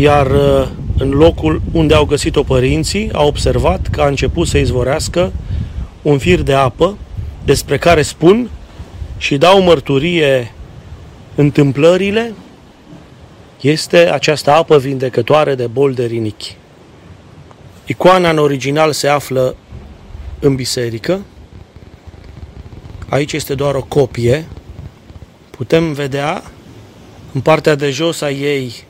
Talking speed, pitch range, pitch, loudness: 110 wpm, 120-155 Hz, 140 Hz, -13 LUFS